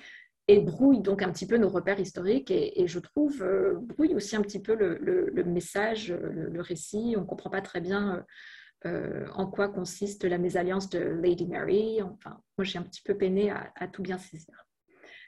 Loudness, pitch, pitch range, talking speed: -29 LUFS, 195 Hz, 180-230 Hz, 210 wpm